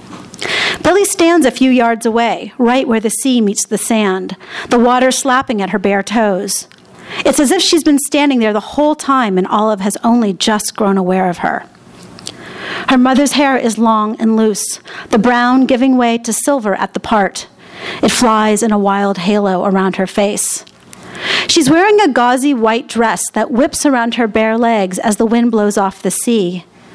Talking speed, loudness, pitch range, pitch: 185 wpm, -12 LUFS, 205-260 Hz, 230 Hz